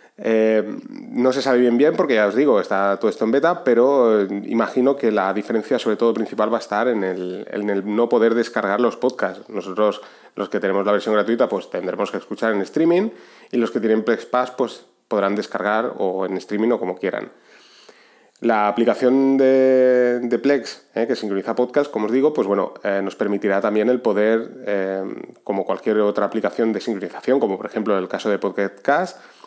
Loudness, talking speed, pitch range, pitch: -20 LUFS, 200 wpm, 105-125 Hz, 110 Hz